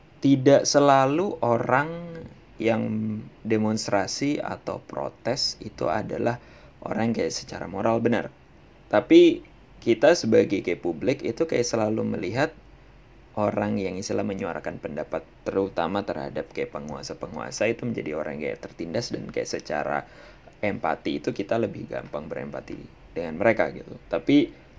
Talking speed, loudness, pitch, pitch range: 125 wpm, -25 LUFS, 125 Hz, 110-155 Hz